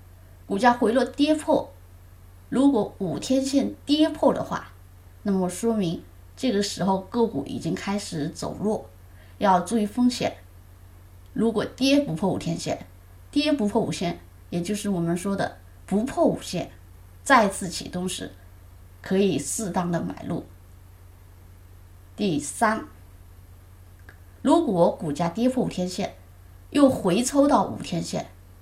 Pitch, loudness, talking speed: 165 Hz, -24 LUFS, 190 characters per minute